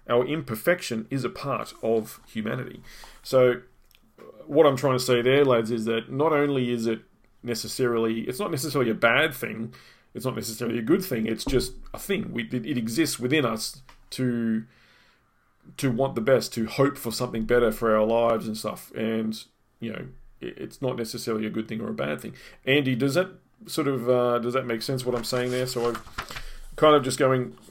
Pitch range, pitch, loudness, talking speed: 115-130 Hz, 120 Hz, -25 LUFS, 200 wpm